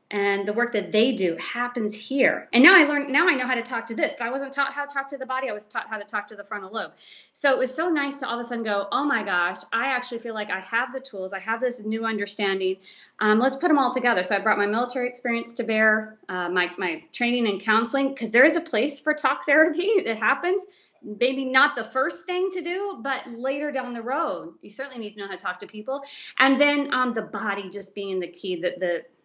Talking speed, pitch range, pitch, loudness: 270 wpm, 210-275 Hz, 240 Hz, -24 LUFS